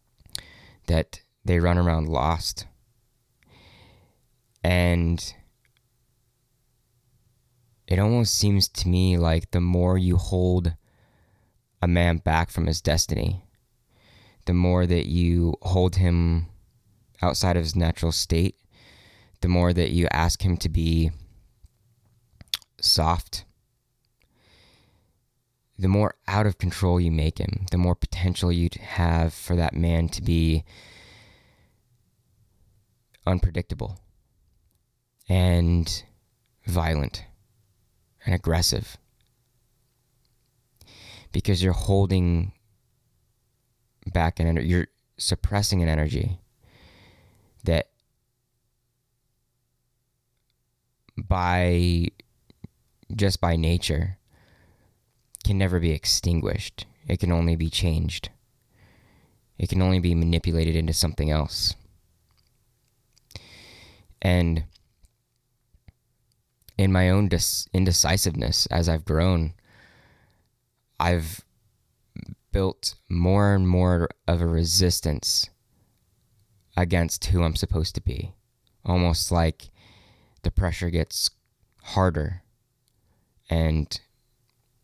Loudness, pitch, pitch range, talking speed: -24 LUFS, 95 Hz, 85-115 Hz, 90 wpm